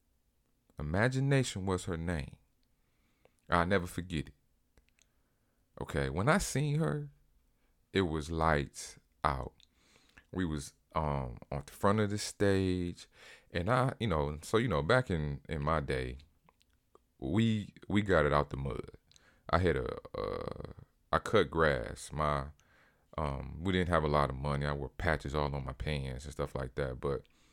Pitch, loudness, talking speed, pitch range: 80 Hz, -34 LUFS, 160 wpm, 70-95 Hz